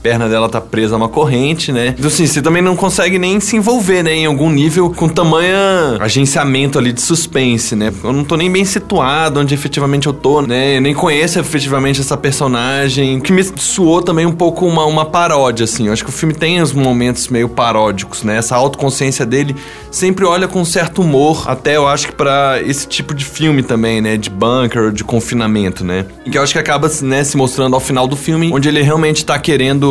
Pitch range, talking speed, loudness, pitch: 125-160 Hz, 220 wpm, -12 LUFS, 140 Hz